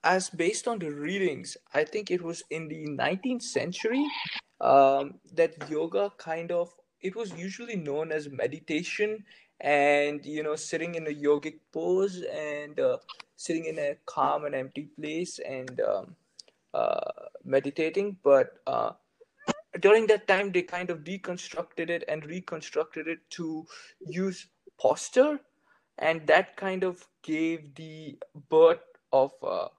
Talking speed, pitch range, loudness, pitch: 140 wpm, 150-195 Hz, -29 LUFS, 165 Hz